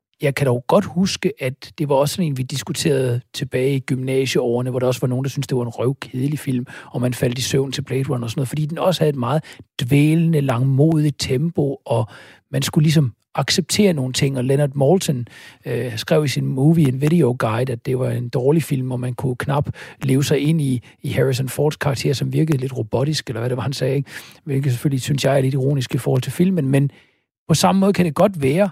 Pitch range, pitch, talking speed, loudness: 130-150 Hz, 140 Hz, 240 wpm, -19 LUFS